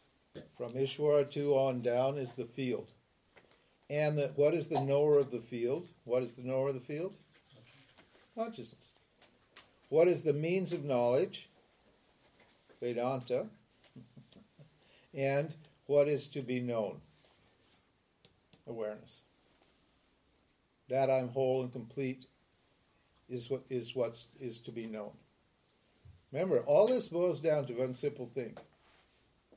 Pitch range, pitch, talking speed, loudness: 125-145 Hz, 135 Hz, 125 wpm, -34 LUFS